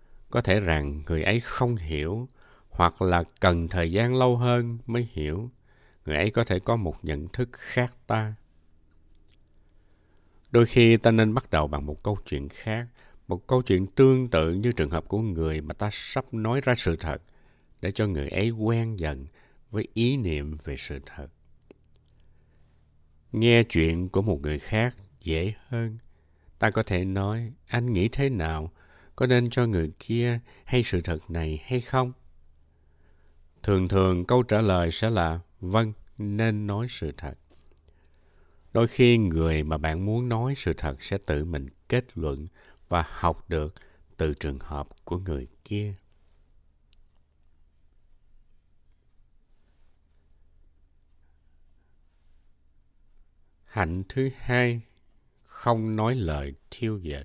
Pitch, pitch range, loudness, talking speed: 85 Hz, 75-110 Hz, -26 LUFS, 145 wpm